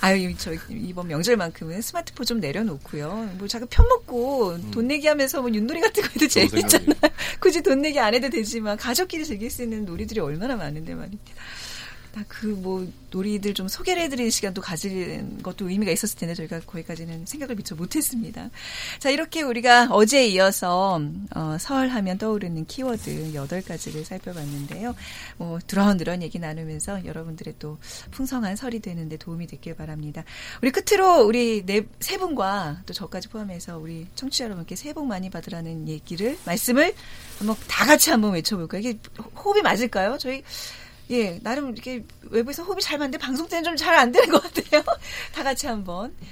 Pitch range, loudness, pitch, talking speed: 175-265 Hz, -23 LUFS, 215 Hz, 385 characters per minute